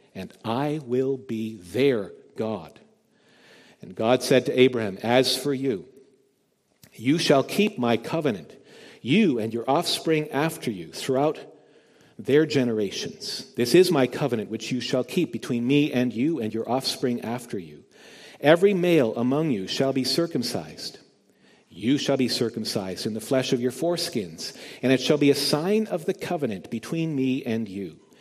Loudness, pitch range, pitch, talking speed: -24 LUFS, 120-150 Hz, 130 Hz, 160 wpm